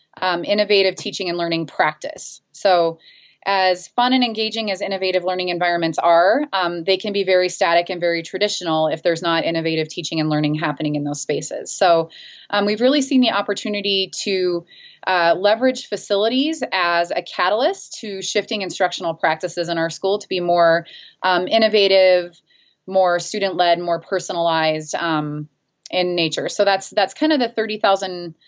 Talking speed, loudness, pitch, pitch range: 160 wpm, -19 LUFS, 185 Hz, 170-205 Hz